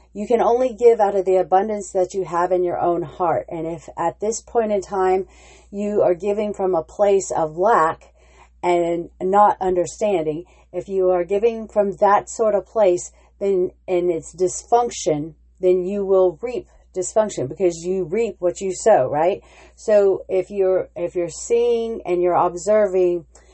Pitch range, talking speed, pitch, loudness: 175-205 Hz, 170 wpm, 185 Hz, -20 LUFS